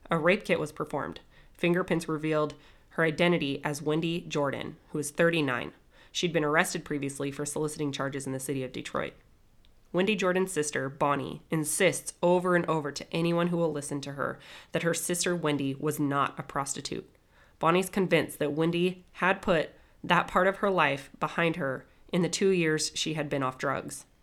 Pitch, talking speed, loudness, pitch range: 155 Hz, 180 wpm, -29 LUFS, 145-175 Hz